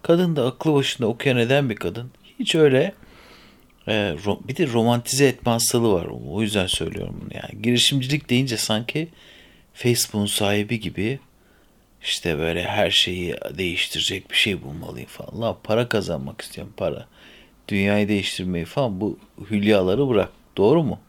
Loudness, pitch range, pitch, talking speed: -22 LUFS, 100-130 Hz, 115 Hz, 140 wpm